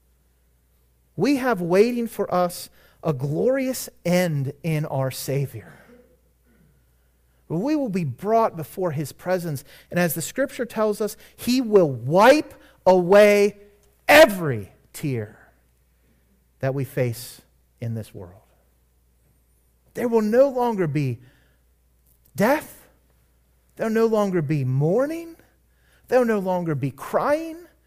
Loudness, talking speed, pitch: -22 LUFS, 115 wpm, 150 Hz